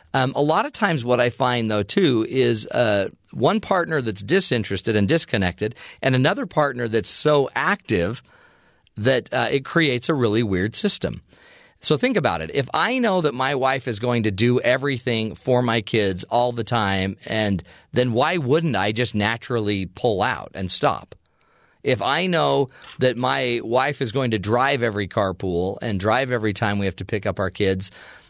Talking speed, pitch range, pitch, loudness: 185 wpm, 105-135 Hz, 120 Hz, -21 LUFS